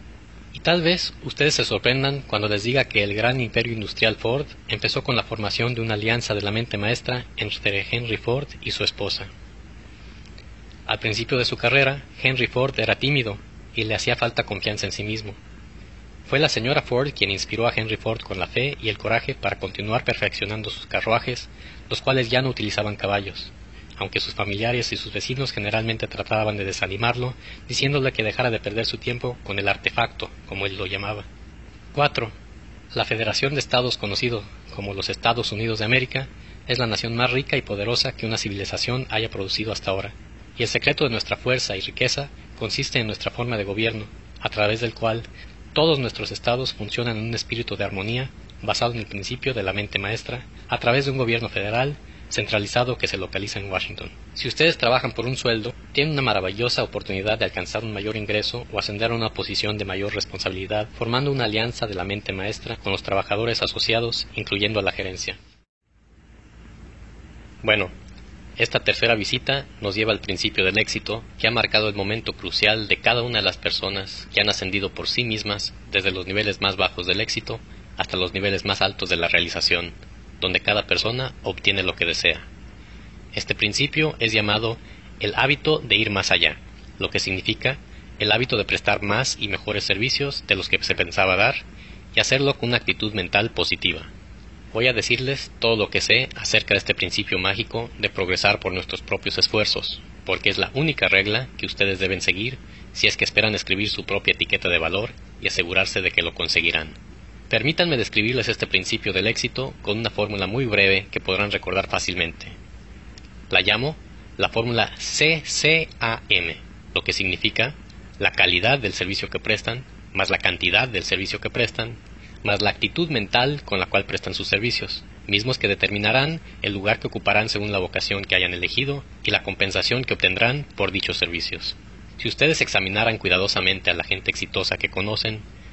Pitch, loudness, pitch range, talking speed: 105 Hz, -22 LUFS, 100-120 Hz, 185 wpm